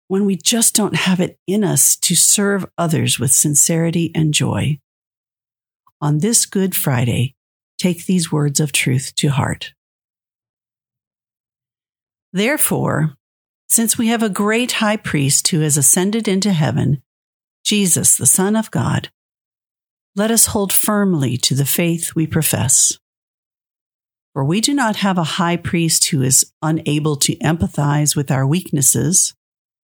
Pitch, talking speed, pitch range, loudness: 155 Hz, 140 wpm, 135-190 Hz, -15 LUFS